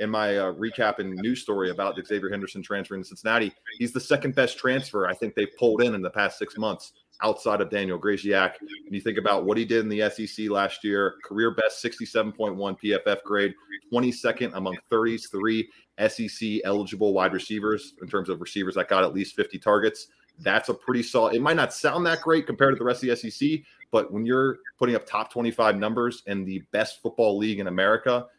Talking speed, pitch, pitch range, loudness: 210 wpm, 110 Hz, 100-120 Hz, -26 LUFS